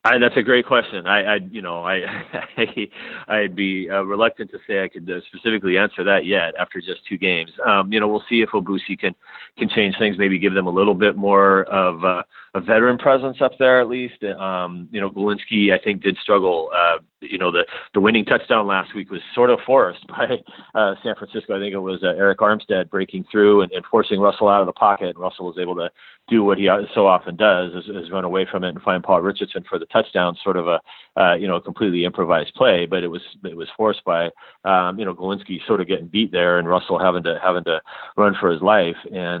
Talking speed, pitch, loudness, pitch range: 235 wpm, 95 Hz, -19 LUFS, 90-105 Hz